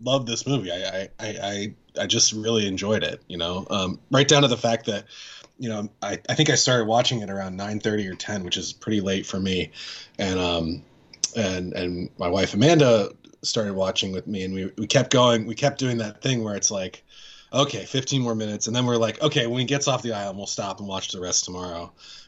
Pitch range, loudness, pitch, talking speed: 95-125 Hz, -23 LUFS, 110 Hz, 230 wpm